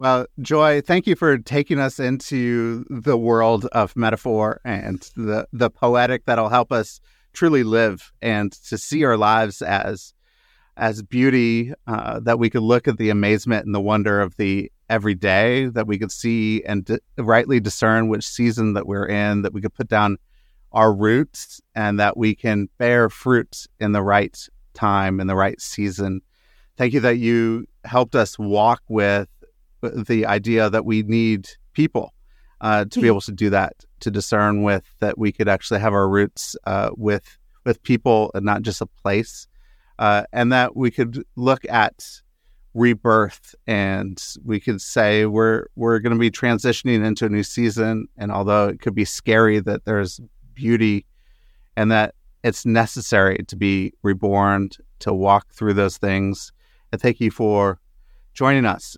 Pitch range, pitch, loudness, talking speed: 100-120 Hz, 110 Hz, -20 LUFS, 170 wpm